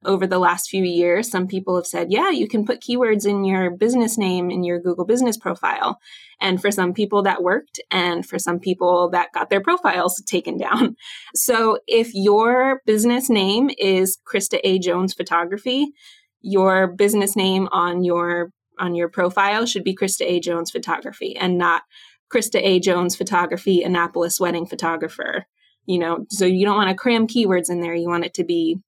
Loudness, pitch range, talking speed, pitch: -20 LUFS, 175-210 Hz, 185 wpm, 190 Hz